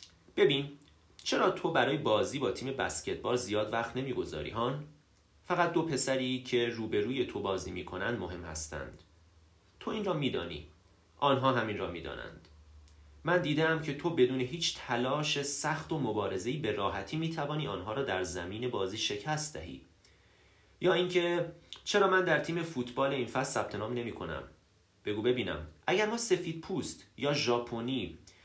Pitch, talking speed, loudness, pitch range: 120 Hz, 150 wpm, -32 LUFS, 90-150 Hz